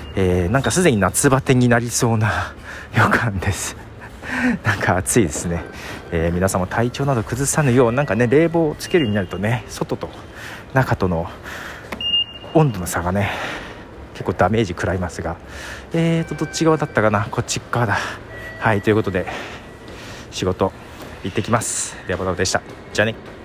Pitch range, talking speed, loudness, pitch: 95-120 Hz, 330 characters per minute, -19 LUFS, 110 Hz